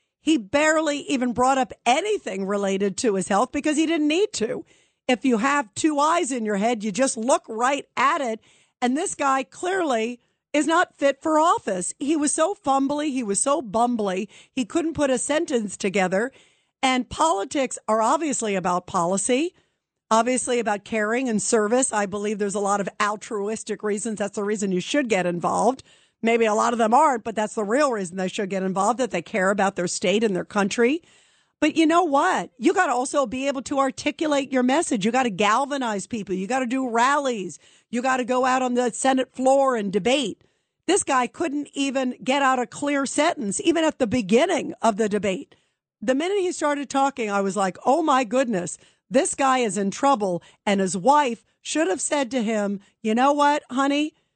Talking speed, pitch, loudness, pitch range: 200 wpm, 255 Hz, -23 LUFS, 210-285 Hz